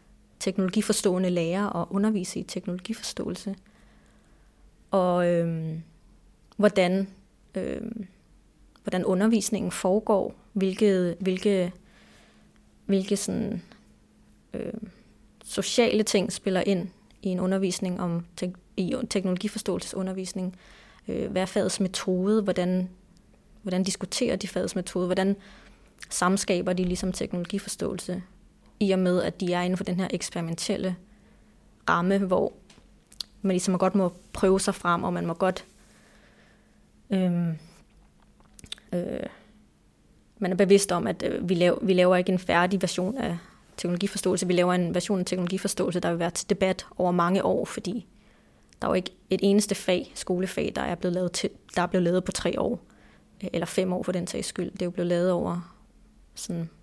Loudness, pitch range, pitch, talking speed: -27 LUFS, 180-200 Hz, 185 Hz, 140 wpm